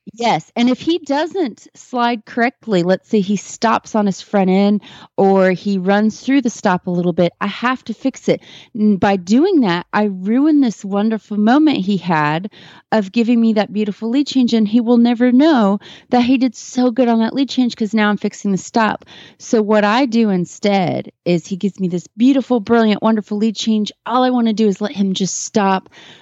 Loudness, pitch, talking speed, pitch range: -16 LUFS, 215 Hz, 210 wpm, 200-245 Hz